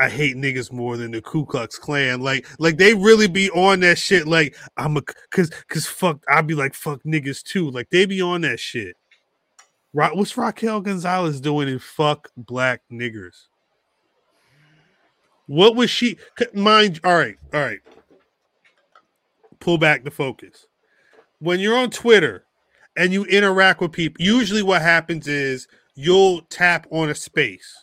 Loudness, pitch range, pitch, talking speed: -19 LUFS, 140-190 Hz, 165 Hz, 155 wpm